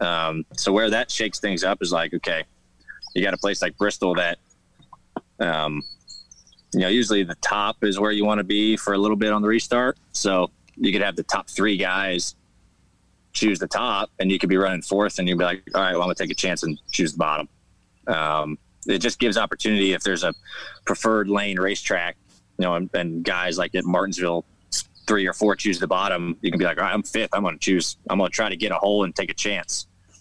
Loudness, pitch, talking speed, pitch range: -23 LUFS, 95 Hz, 235 wpm, 90-105 Hz